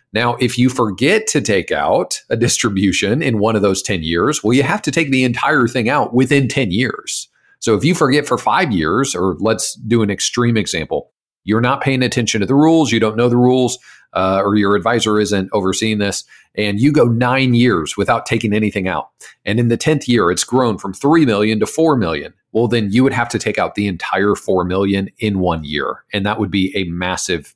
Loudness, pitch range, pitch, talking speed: -16 LUFS, 100-125 Hz, 115 Hz, 220 wpm